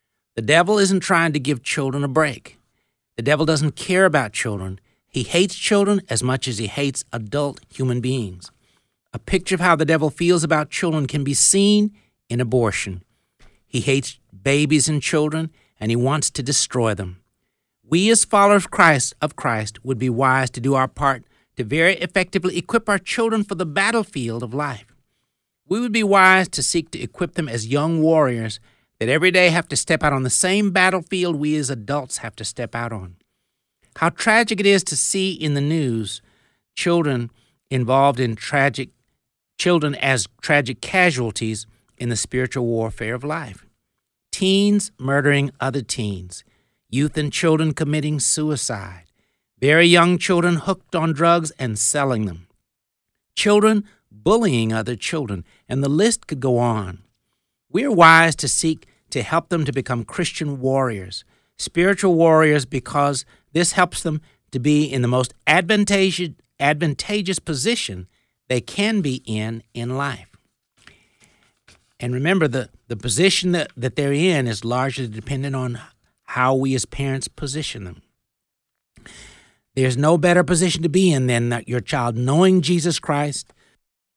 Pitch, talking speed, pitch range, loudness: 140 Hz, 160 wpm, 120-170 Hz, -19 LUFS